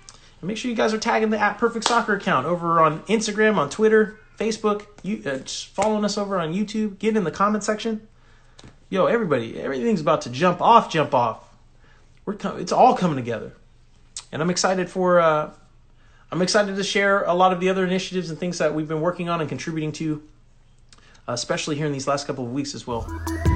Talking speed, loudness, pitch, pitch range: 205 wpm, -22 LUFS, 180 Hz, 150-210 Hz